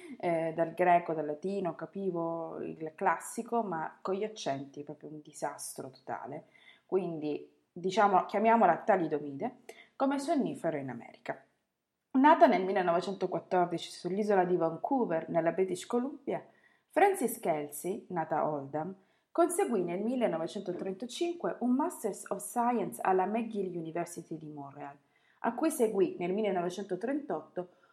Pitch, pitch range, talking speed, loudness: 185 Hz, 165-225 Hz, 120 wpm, -32 LUFS